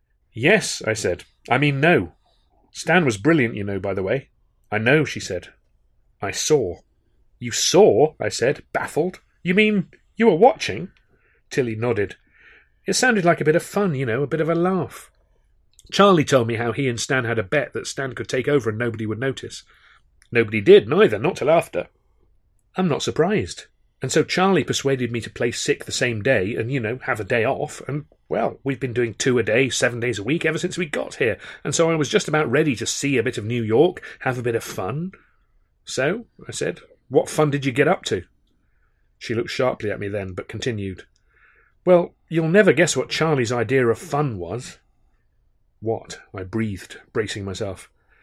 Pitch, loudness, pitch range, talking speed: 135 Hz, -21 LUFS, 110-165 Hz, 200 wpm